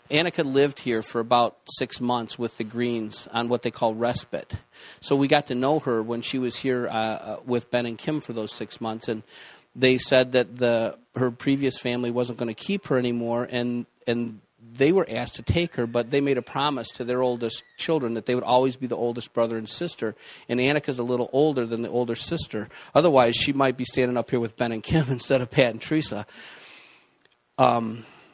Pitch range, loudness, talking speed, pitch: 115-130 Hz, -25 LUFS, 220 wpm, 120 Hz